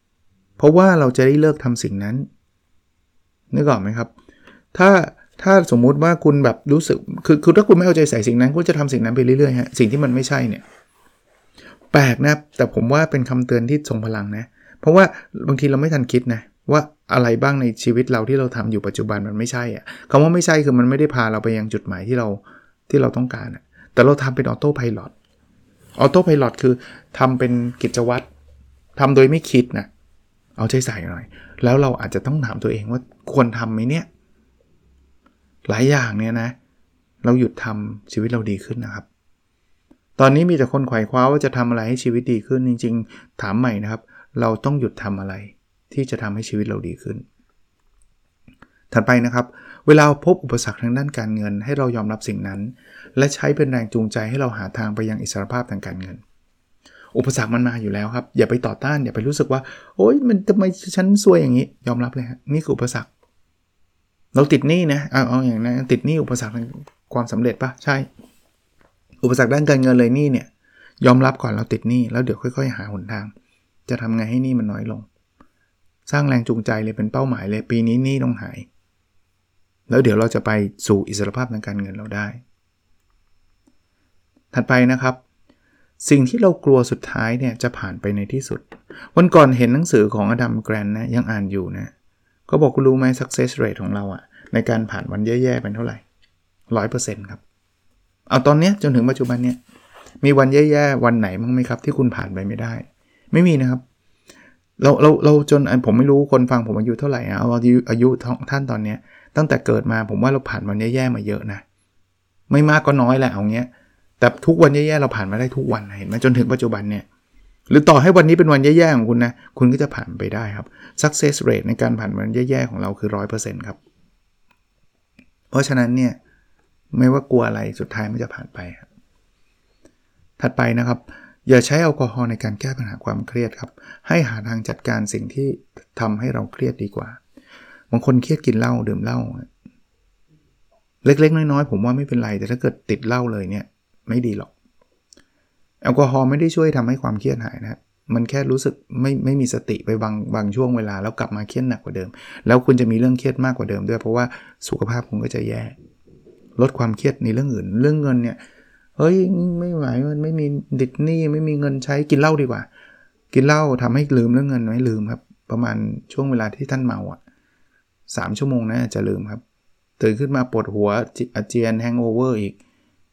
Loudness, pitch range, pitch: -18 LUFS, 110-135 Hz, 120 Hz